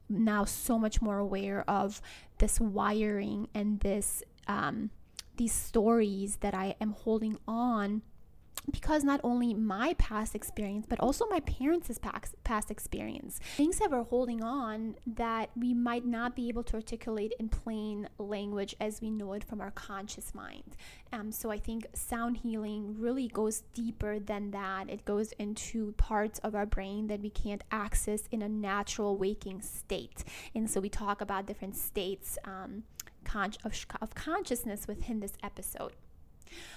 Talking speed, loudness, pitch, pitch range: 160 wpm, -35 LUFS, 215 Hz, 205-235 Hz